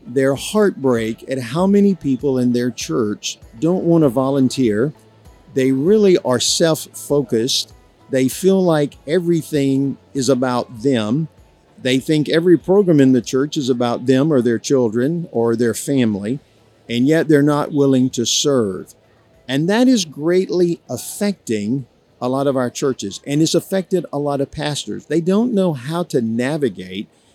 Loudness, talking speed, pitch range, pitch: -17 LUFS, 155 wpm, 120-160 Hz, 135 Hz